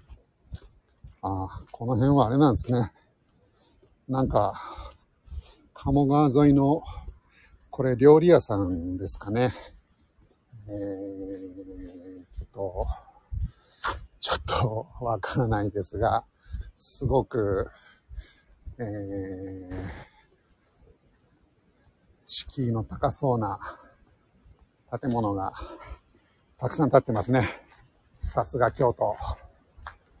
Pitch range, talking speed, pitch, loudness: 90-125 Hz, 155 characters per minute, 100 Hz, -26 LUFS